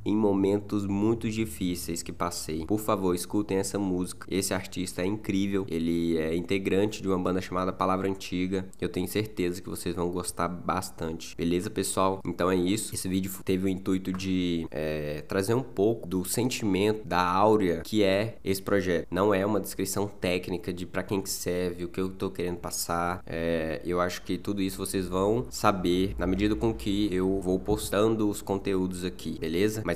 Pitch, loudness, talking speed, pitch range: 95 Hz, -29 LUFS, 180 wpm, 90-100 Hz